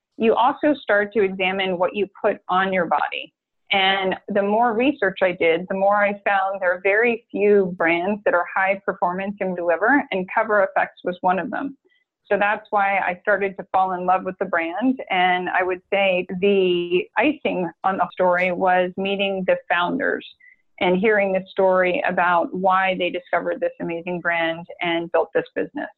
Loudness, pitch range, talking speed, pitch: -21 LUFS, 180-205 Hz, 180 wpm, 190 Hz